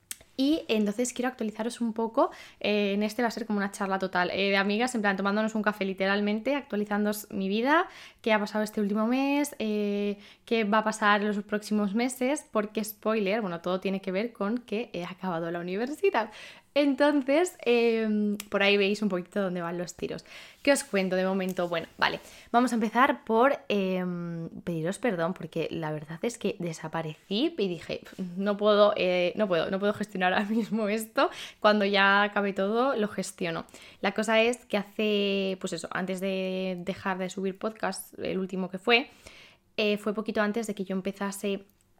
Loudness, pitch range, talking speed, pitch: -28 LUFS, 190-225 Hz, 185 wpm, 205 Hz